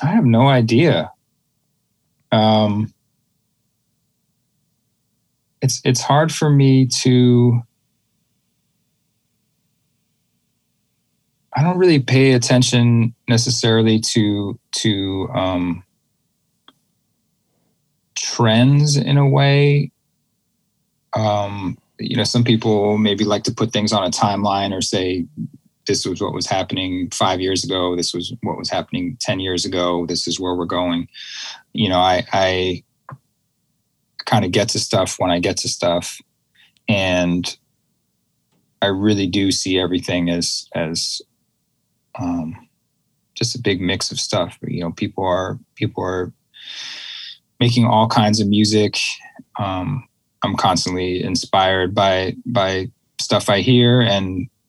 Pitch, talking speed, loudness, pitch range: 105 Hz, 120 wpm, -18 LUFS, 95-125 Hz